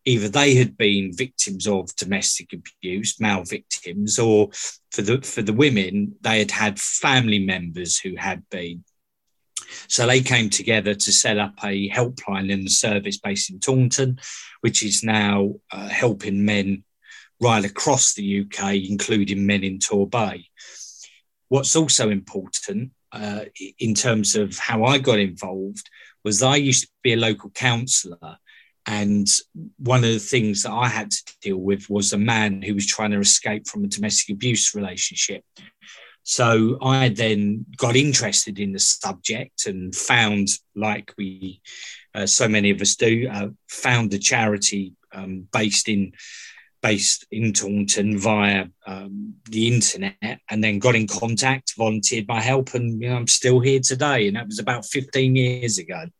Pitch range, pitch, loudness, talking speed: 100-125 Hz, 105 Hz, -20 LUFS, 160 wpm